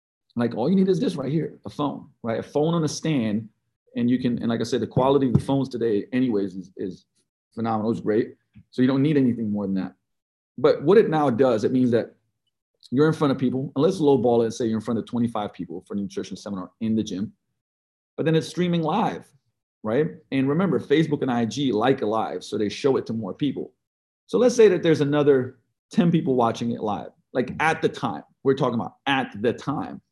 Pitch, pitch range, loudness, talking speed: 125 Hz, 115-145 Hz, -23 LUFS, 235 wpm